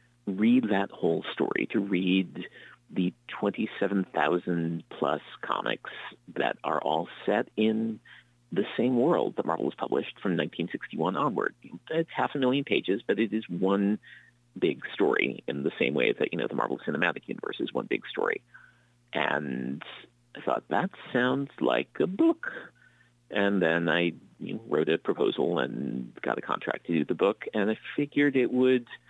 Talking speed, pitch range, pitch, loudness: 165 wpm, 90-125 Hz, 110 Hz, -29 LUFS